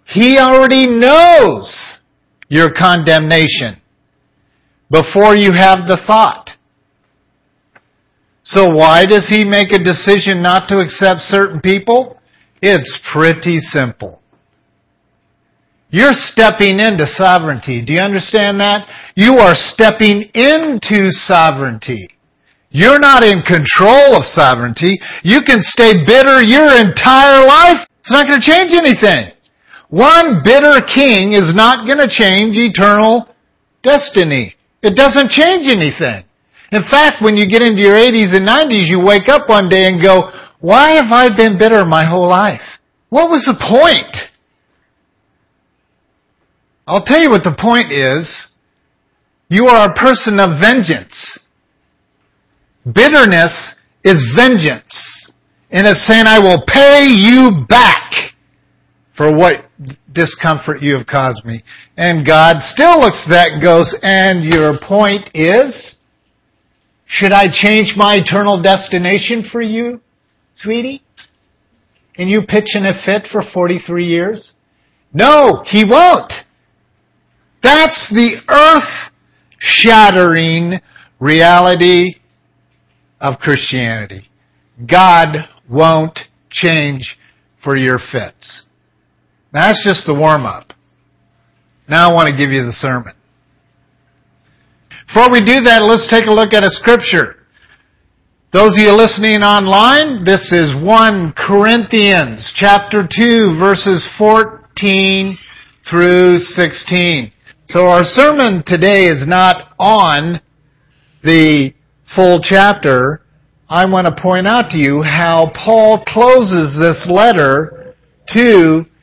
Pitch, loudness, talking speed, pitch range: 190 Hz, -8 LUFS, 120 wpm, 160-225 Hz